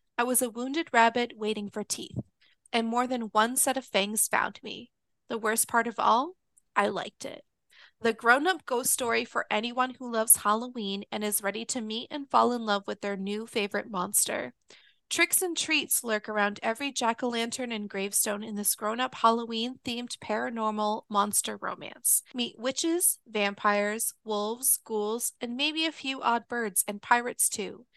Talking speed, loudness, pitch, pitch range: 180 wpm, -28 LUFS, 230 Hz, 210-250 Hz